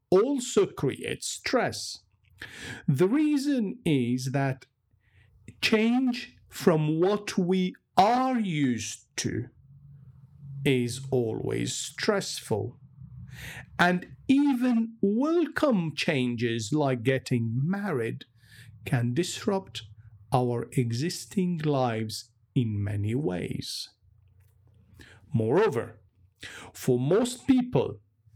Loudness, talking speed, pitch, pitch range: -27 LUFS, 75 wpm, 130 Hz, 110-185 Hz